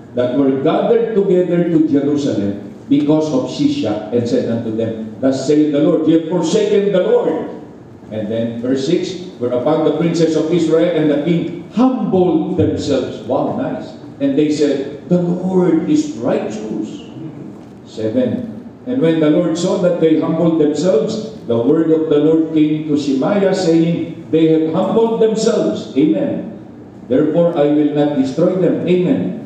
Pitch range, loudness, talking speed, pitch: 145-180 Hz, -15 LUFS, 155 wpm, 160 Hz